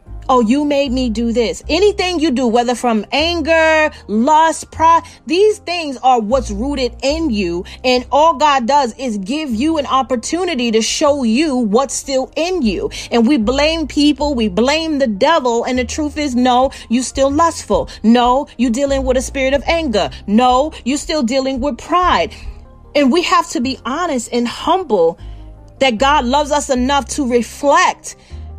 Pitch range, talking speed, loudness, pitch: 245-310 Hz, 170 wpm, -15 LUFS, 270 Hz